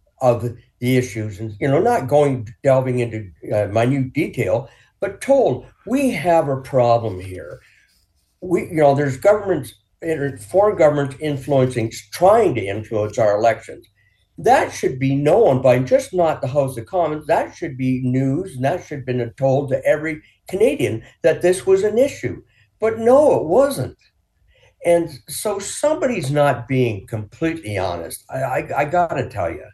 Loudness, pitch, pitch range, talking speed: -19 LUFS, 135 Hz, 120-165 Hz, 160 wpm